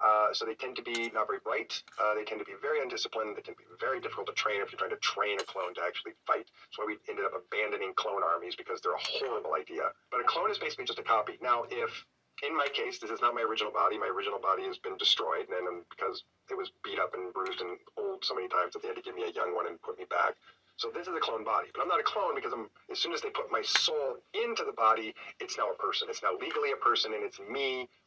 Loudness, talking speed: -33 LUFS, 285 wpm